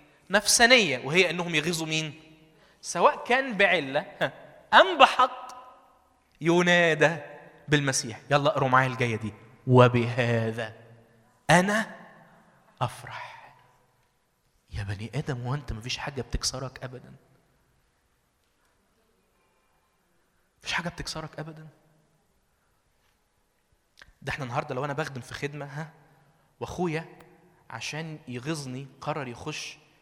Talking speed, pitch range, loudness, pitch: 95 wpm, 130-170 Hz, -25 LUFS, 150 Hz